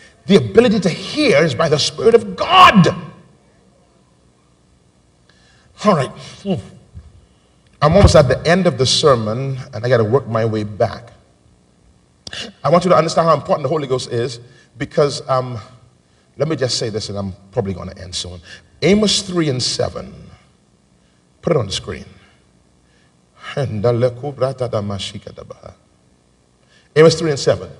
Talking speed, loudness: 140 wpm, -16 LUFS